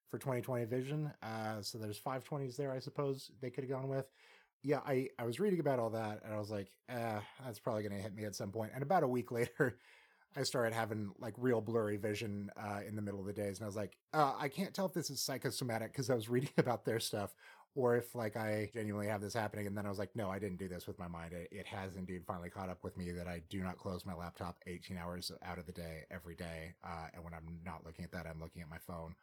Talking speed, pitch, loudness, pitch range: 275 wpm, 105 Hz, -41 LUFS, 90-125 Hz